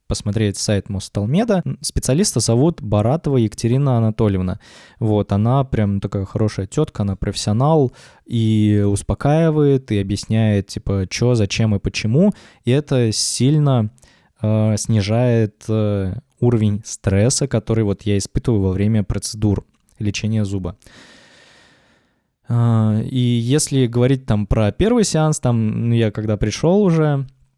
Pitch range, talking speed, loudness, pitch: 105-130 Hz, 120 wpm, -18 LUFS, 110 Hz